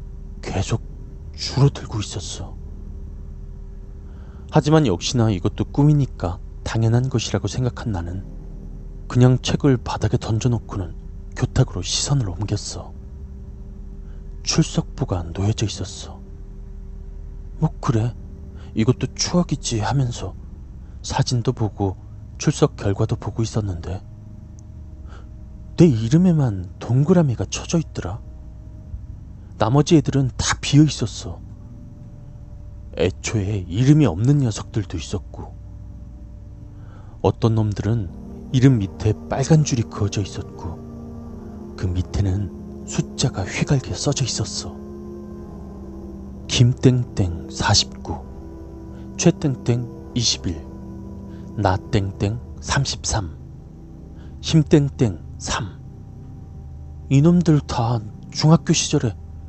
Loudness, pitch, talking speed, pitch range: -21 LUFS, 100 Hz, 195 characters per minute, 85-120 Hz